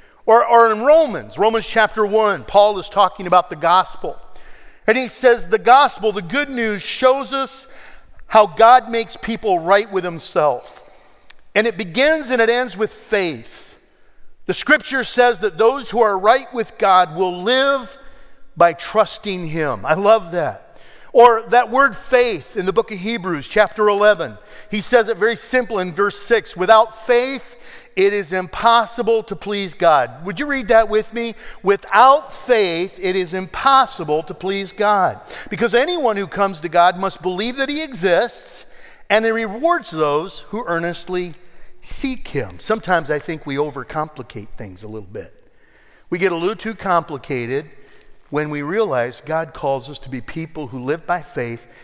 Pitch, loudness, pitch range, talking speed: 210 Hz, -17 LUFS, 175-235 Hz, 165 wpm